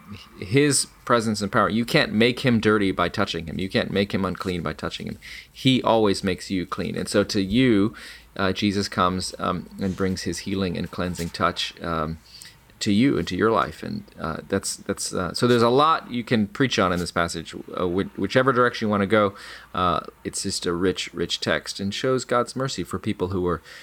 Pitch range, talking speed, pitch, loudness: 90-115 Hz, 215 wpm, 100 Hz, -23 LUFS